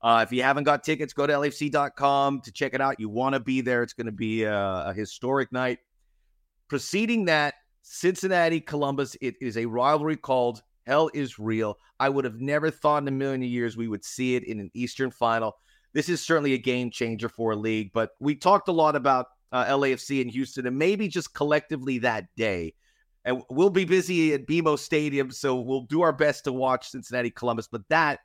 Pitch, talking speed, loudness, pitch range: 130 Hz, 210 wpm, -26 LUFS, 120-150 Hz